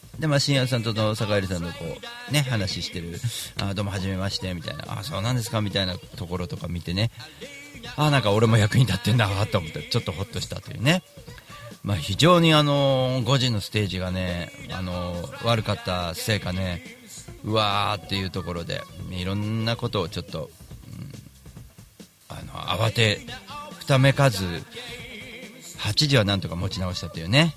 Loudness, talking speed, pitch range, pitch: -24 LUFS, 320 characters per minute, 95-130 Hz, 105 Hz